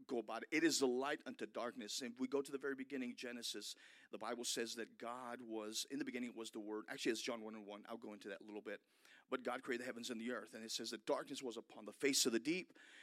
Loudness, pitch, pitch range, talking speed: -44 LUFS, 120 Hz, 110-130 Hz, 295 wpm